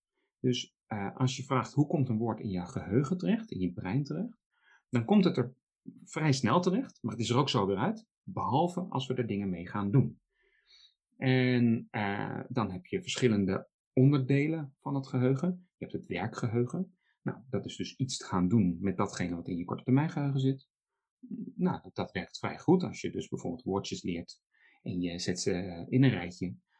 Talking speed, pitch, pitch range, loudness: 200 wpm, 130 Hz, 105-160 Hz, -32 LUFS